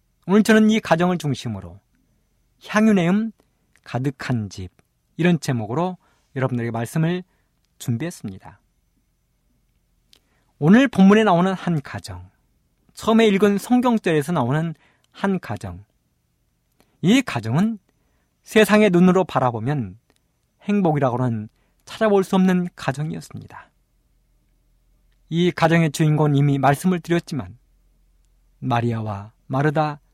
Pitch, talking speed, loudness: 145 Hz, 250 characters per minute, -20 LUFS